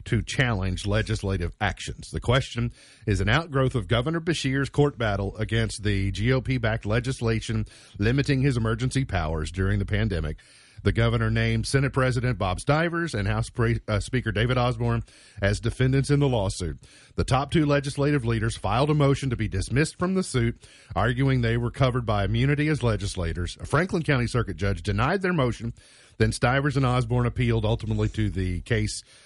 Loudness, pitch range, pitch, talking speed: -25 LUFS, 105-135 Hz, 115 Hz, 170 wpm